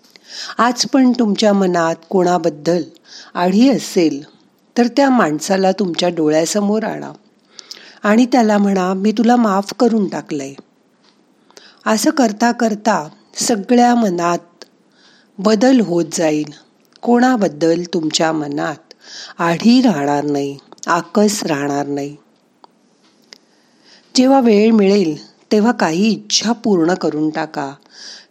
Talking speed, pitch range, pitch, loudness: 100 wpm, 165-230 Hz, 195 Hz, -15 LUFS